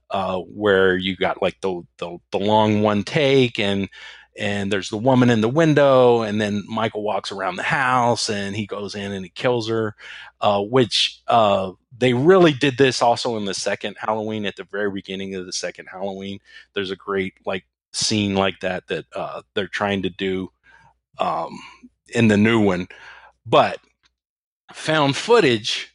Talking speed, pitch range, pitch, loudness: 175 wpm, 95-120 Hz, 105 Hz, -20 LUFS